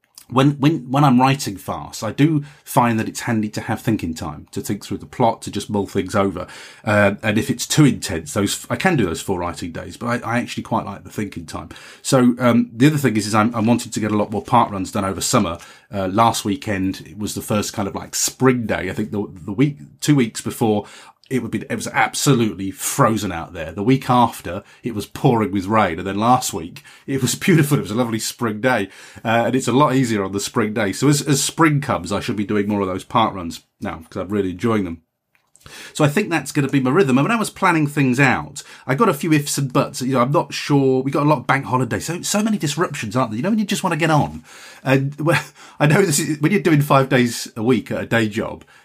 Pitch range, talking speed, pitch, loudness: 105-140 Hz, 265 wpm, 120 Hz, -19 LUFS